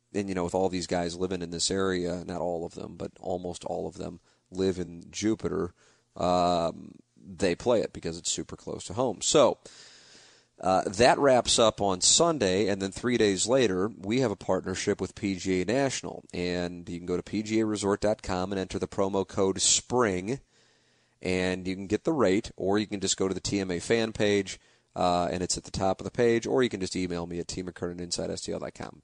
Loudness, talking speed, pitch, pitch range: -28 LUFS, 200 wpm, 95 Hz, 90-100 Hz